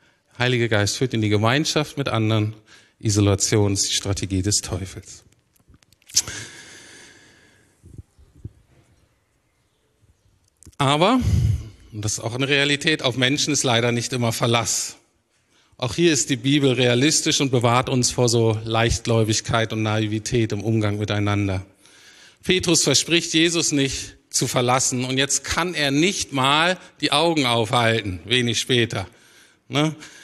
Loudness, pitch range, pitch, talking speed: -20 LUFS, 105-140 Hz, 115 Hz, 125 wpm